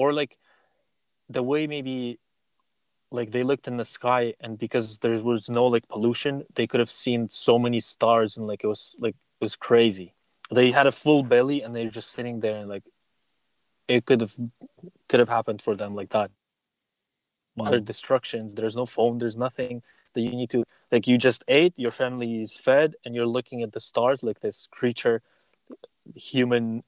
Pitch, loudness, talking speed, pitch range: 120 Hz, -25 LUFS, 190 wpm, 115-130 Hz